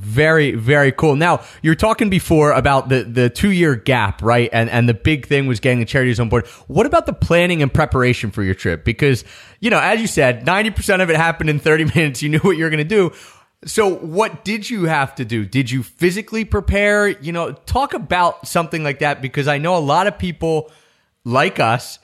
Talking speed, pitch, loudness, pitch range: 220 wpm, 150 Hz, -16 LUFS, 125-175 Hz